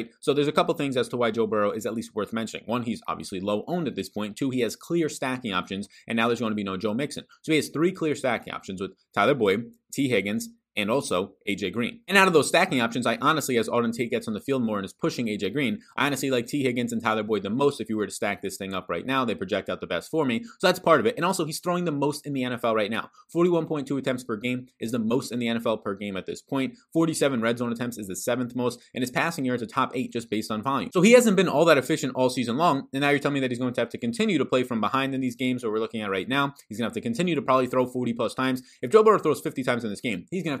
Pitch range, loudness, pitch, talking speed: 115-160 Hz, -26 LUFS, 130 Hz, 310 wpm